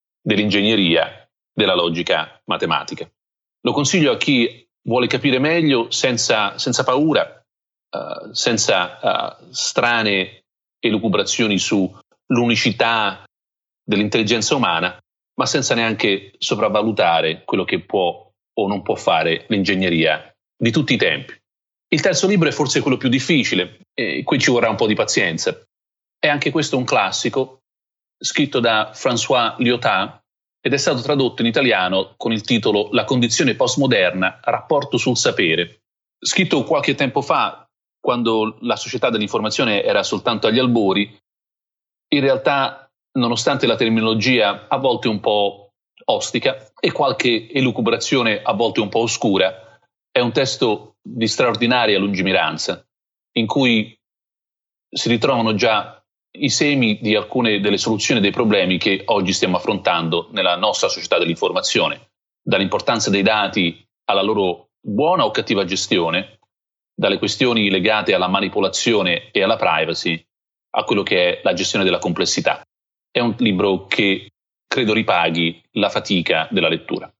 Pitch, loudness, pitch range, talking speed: 110 Hz, -18 LUFS, 100-125 Hz, 130 wpm